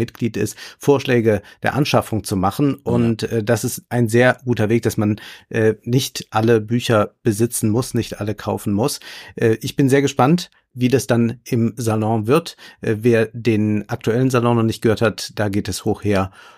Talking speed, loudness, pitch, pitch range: 190 wpm, -19 LUFS, 115 Hz, 110-125 Hz